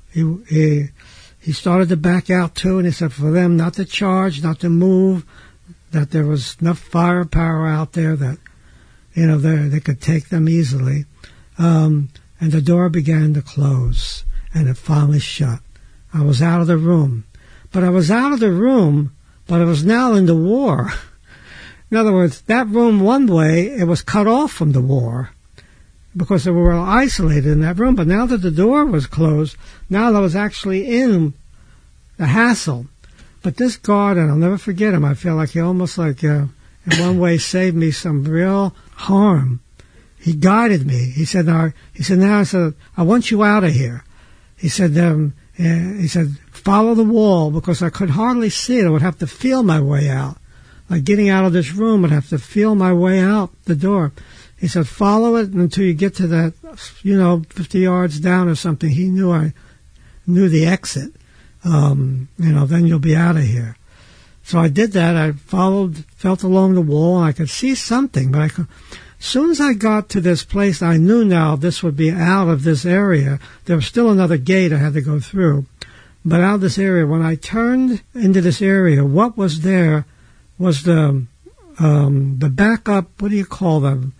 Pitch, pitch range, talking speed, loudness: 170 Hz, 150-190 Hz, 200 wpm, -16 LUFS